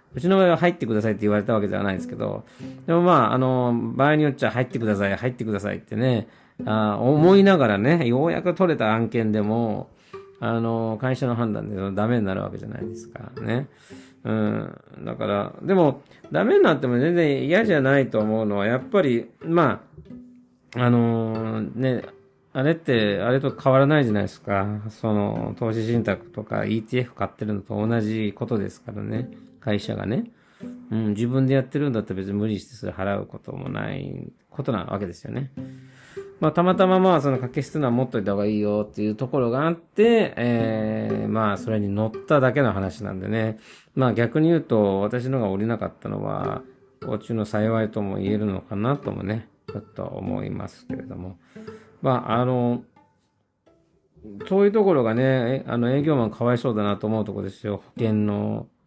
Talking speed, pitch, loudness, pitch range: 365 characters per minute, 120 Hz, -23 LUFS, 105-135 Hz